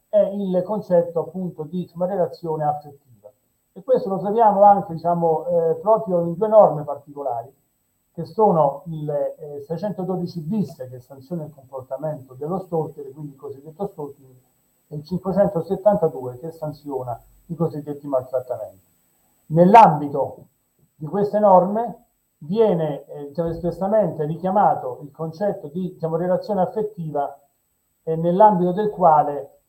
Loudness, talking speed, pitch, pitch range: -20 LUFS, 130 wpm, 165 Hz, 145-190 Hz